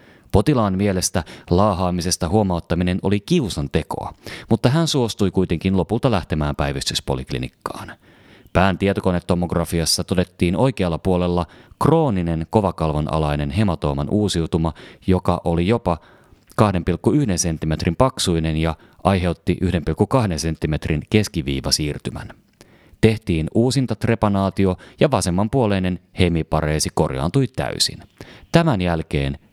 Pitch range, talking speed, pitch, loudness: 80-105 Hz, 90 wpm, 90 Hz, -20 LUFS